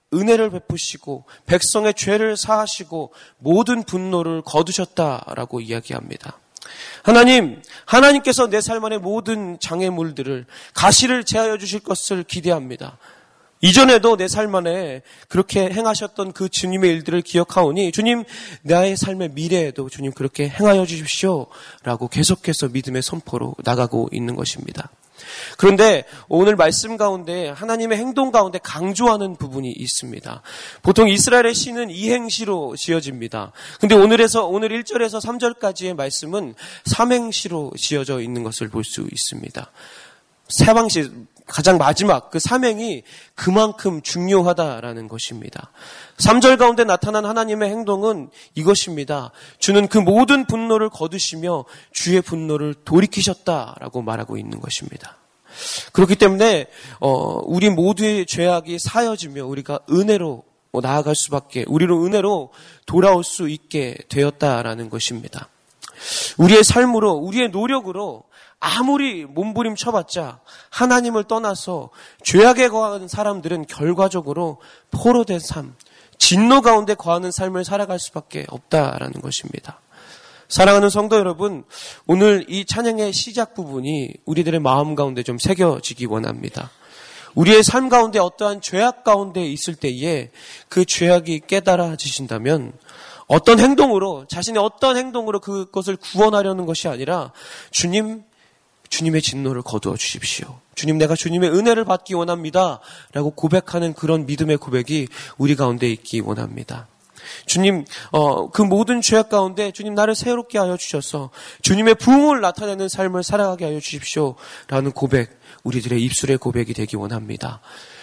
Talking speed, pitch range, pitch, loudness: 325 characters per minute, 150-210 Hz, 180 Hz, -18 LUFS